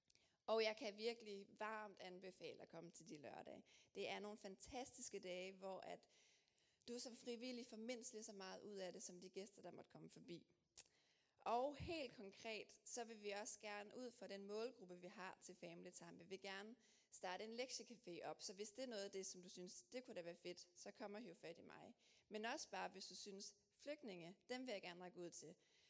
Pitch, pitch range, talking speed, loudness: 205 Hz, 185-230 Hz, 220 wpm, -54 LUFS